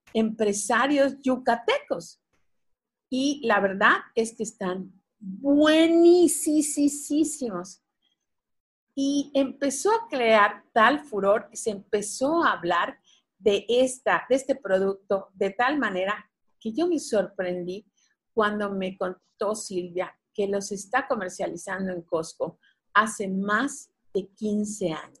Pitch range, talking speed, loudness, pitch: 195-275 Hz, 110 wpm, -25 LUFS, 215 Hz